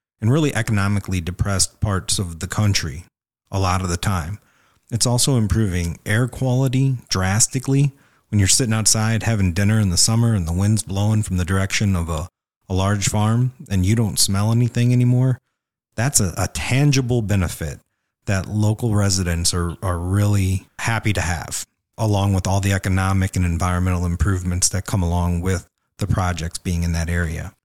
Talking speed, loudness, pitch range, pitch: 170 wpm, -20 LUFS, 90-115 Hz, 100 Hz